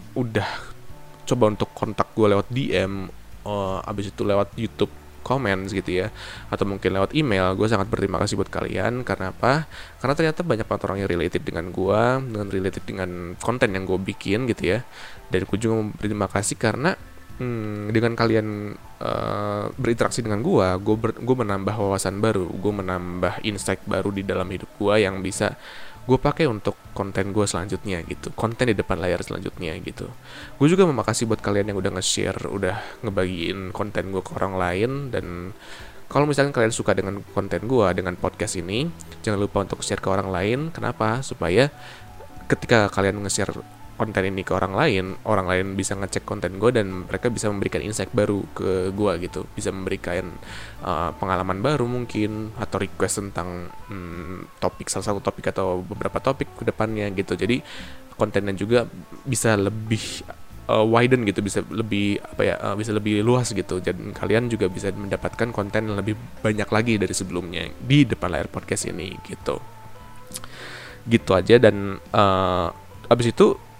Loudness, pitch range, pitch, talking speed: -23 LUFS, 95-110 Hz, 100 Hz, 170 wpm